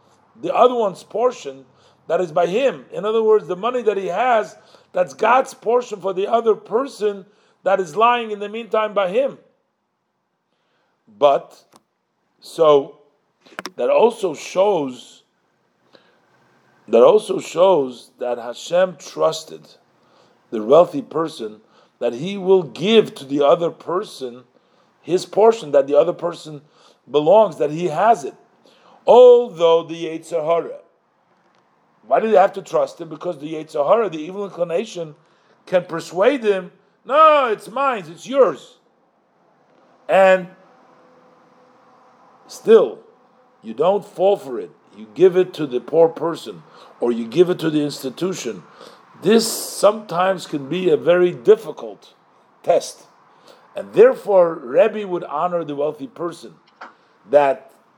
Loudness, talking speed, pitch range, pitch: -18 LUFS, 130 wpm, 160-230 Hz, 185 Hz